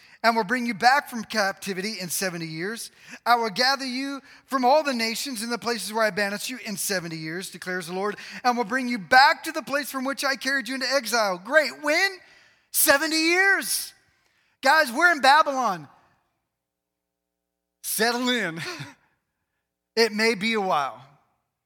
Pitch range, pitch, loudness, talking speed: 195-275 Hz, 235 Hz, -23 LUFS, 170 wpm